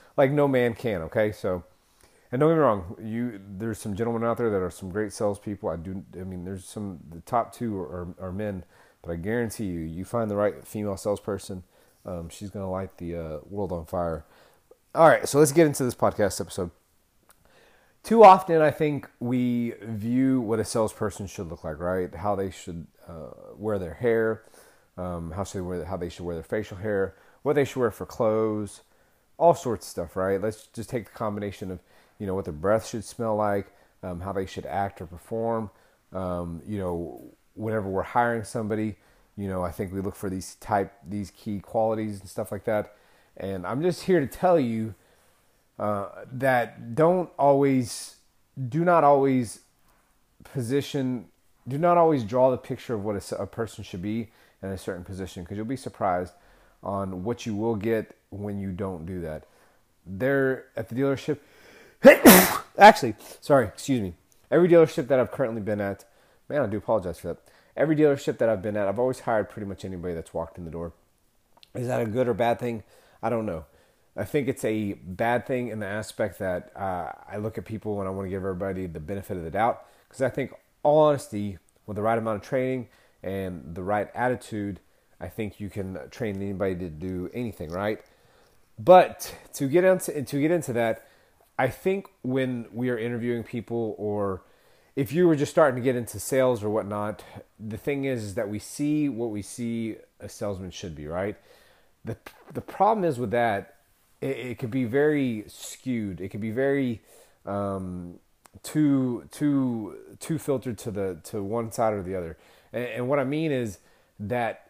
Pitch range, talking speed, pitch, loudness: 95-125 Hz, 195 wpm, 105 Hz, -26 LUFS